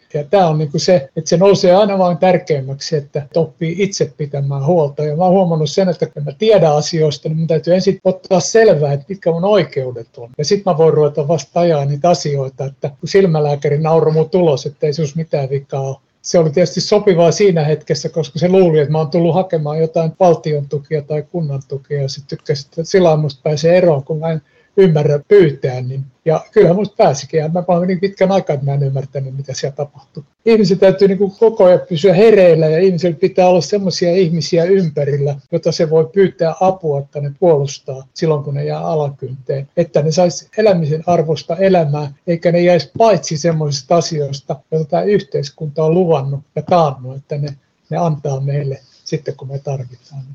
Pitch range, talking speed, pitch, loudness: 145-180 Hz, 190 wpm, 160 Hz, -14 LUFS